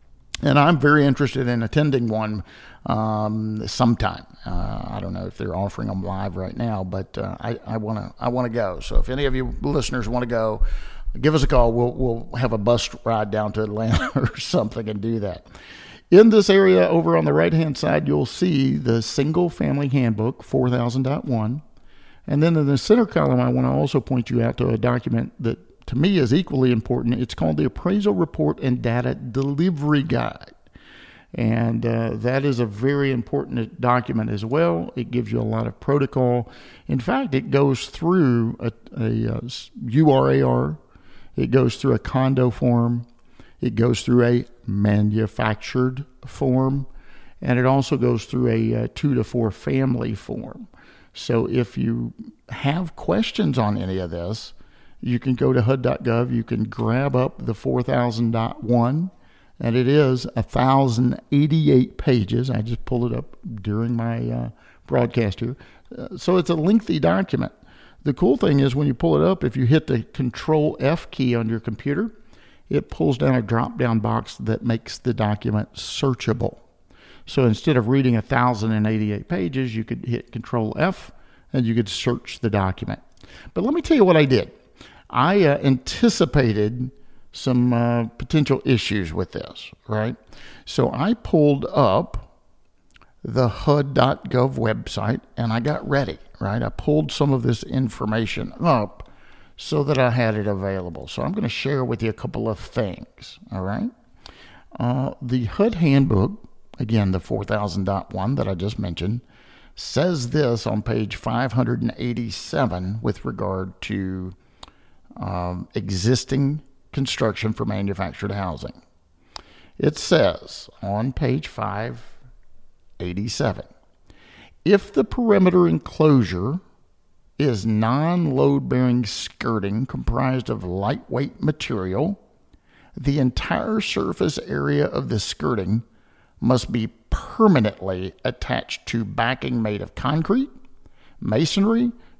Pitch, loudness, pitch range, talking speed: 120 Hz, -22 LUFS, 110-135 Hz, 150 wpm